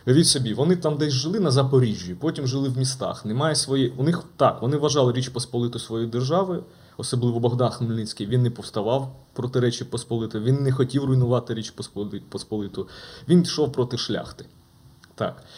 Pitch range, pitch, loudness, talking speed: 115-140 Hz, 125 Hz, -24 LUFS, 165 wpm